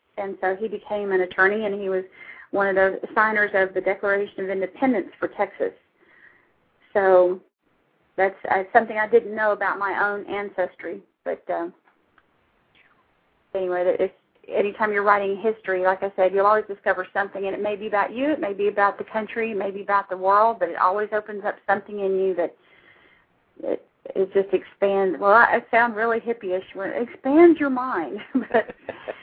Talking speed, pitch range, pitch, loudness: 180 wpm, 190-220 Hz, 200 Hz, -22 LUFS